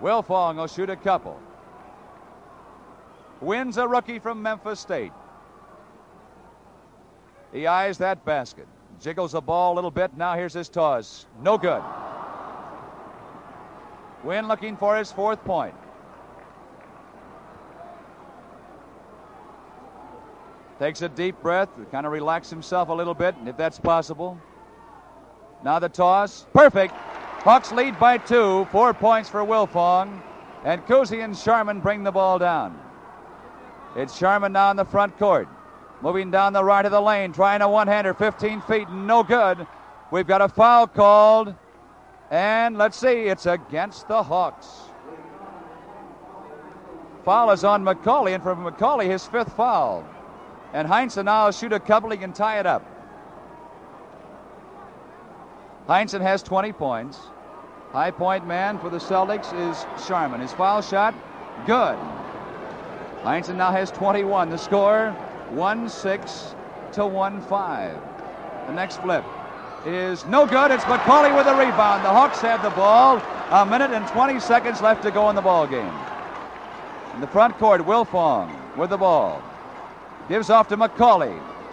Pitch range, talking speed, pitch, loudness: 185-220 Hz, 140 wpm, 200 Hz, -21 LUFS